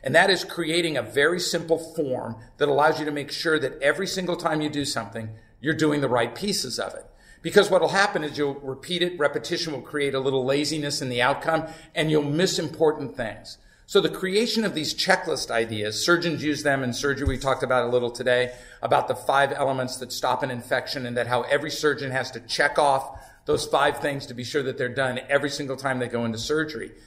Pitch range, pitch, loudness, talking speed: 125-160 Hz, 145 Hz, -24 LUFS, 225 wpm